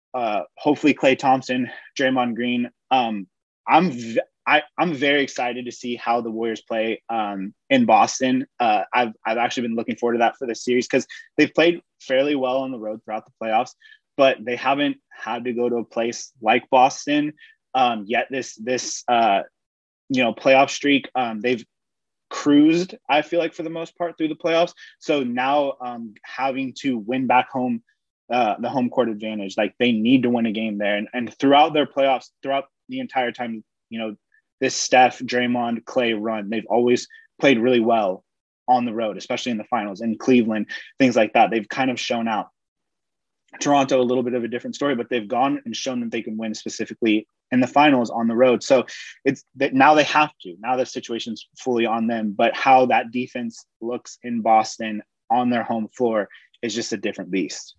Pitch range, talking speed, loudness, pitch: 115-140 Hz, 195 wpm, -21 LUFS, 125 Hz